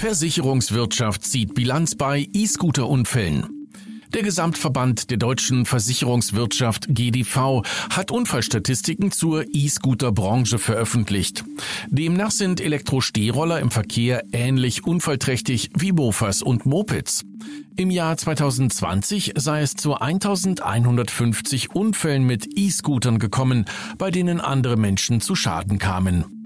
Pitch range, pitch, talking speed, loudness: 120-165 Hz, 130 Hz, 100 wpm, -20 LUFS